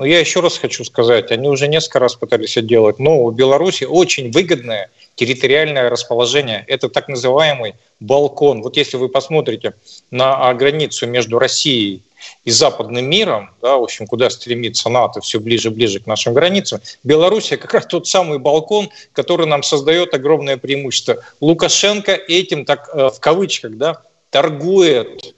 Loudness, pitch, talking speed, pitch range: -14 LUFS, 145 Hz, 155 wpm, 120-165 Hz